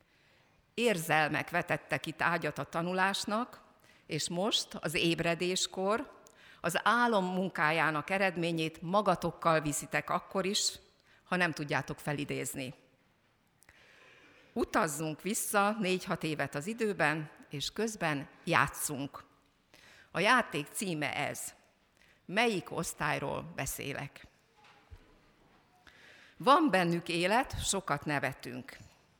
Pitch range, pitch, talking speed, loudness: 155-195 Hz, 170 Hz, 90 wpm, -32 LUFS